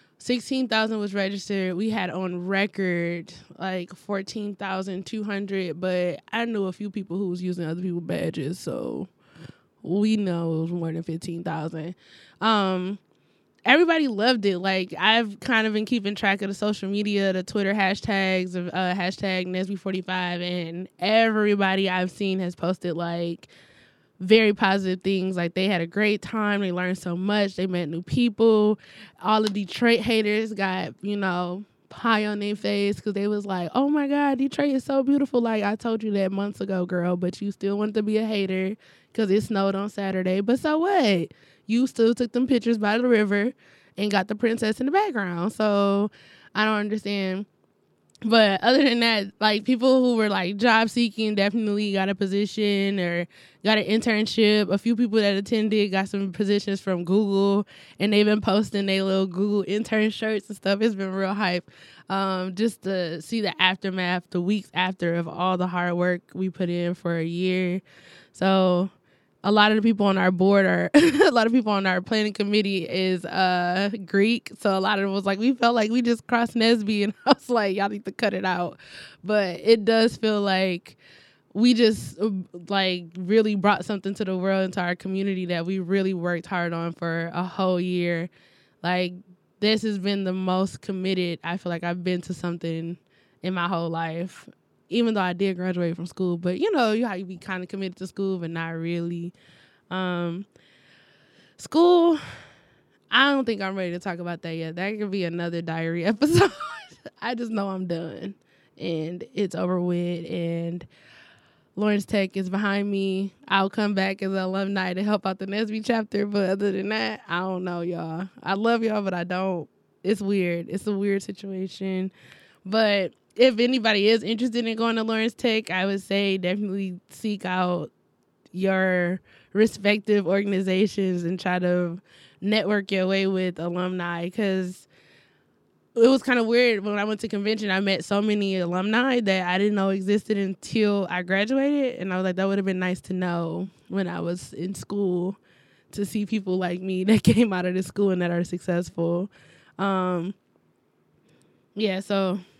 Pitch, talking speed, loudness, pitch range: 195 Hz, 185 wpm, -24 LUFS, 180-215 Hz